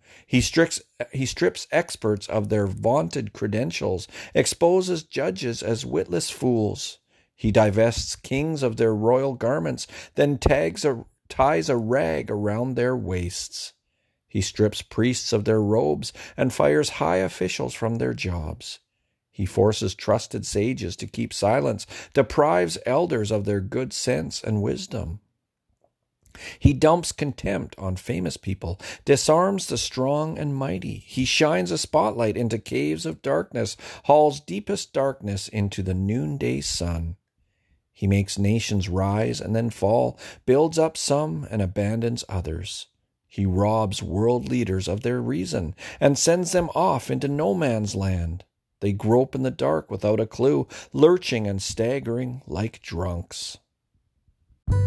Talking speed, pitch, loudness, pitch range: 135 wpm, 110 Hz, -24 LUFS, 95-130 Hz